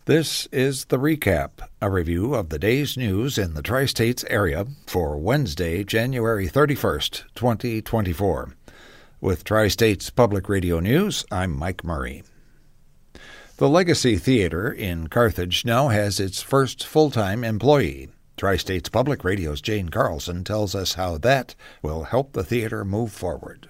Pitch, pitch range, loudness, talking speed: 105 Hz, 90-130 Hz, -22 LUFS, 135 wpm